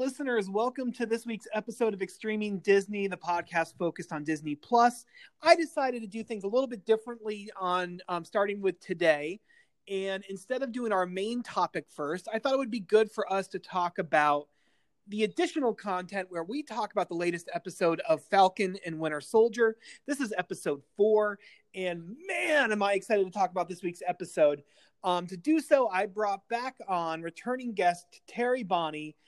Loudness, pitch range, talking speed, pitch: -30 LUFS, 180-235 Hz, 185 wpm, 200 Hz